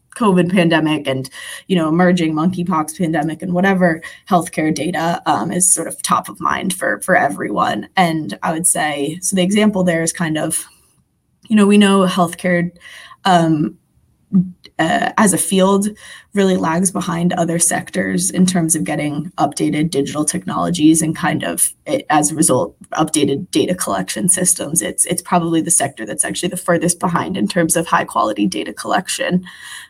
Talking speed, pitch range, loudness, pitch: 165 wpm, 160-180 Hz, -16 LUFS, 175 Hz